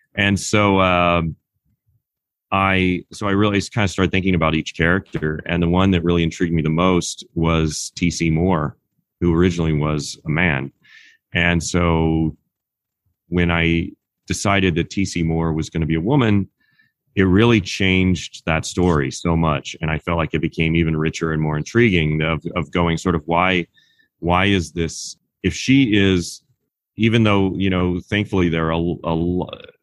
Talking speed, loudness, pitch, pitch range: 170 wpm, -19 LUFS, 85 Hz, 80-95 Hz